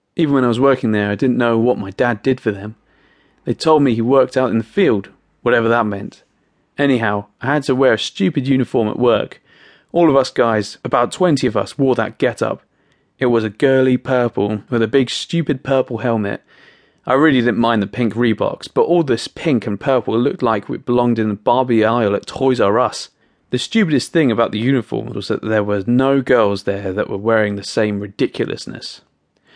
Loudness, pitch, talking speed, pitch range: -17 LUFS, 120 Hz, 210 wpm, 110-130 Hz